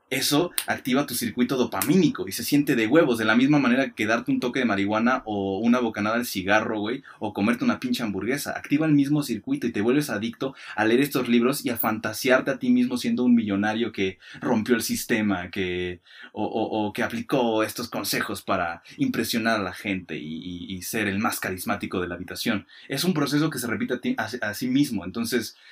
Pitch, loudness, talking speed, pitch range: 115 Hz, -24 LUFS, 215 wpm, 105-130 Hz